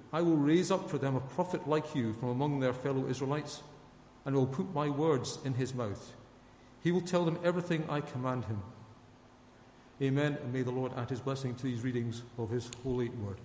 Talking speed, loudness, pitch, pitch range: 205 wpm, -34 LUFS, 130 Hz, 125-145 Hz